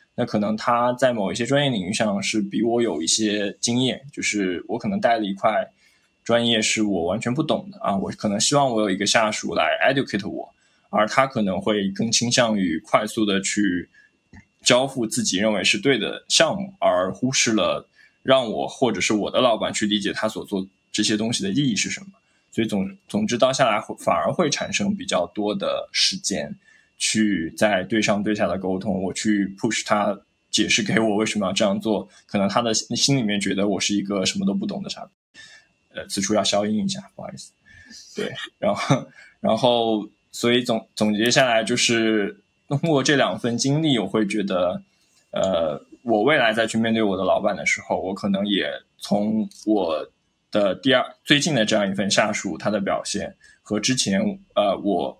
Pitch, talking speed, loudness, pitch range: 110 Hz, 280 characters per minute, -22 LUFS, 100-120 Hz